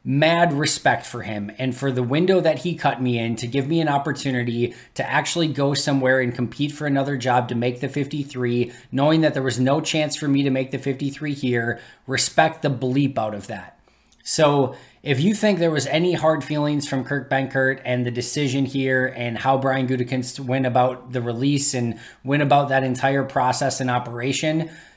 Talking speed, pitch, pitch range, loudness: 195 wpm, 135 Hz, 125-145 Hz, -21 LUFS